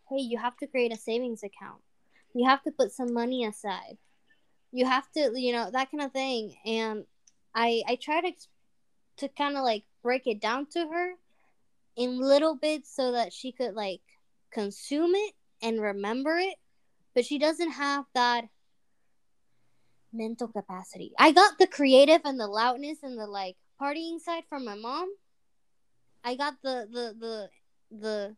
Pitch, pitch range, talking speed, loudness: 250 Hz, 225-290 Hz, 165 wpm, -28 LUFS